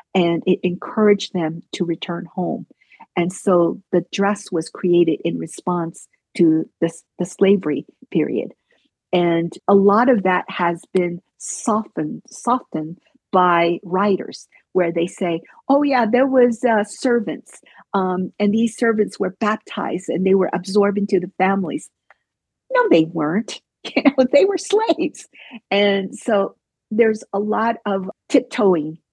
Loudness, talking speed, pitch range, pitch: -19 LUFS, 135 wpm, 175-225 Hz, 195 Hz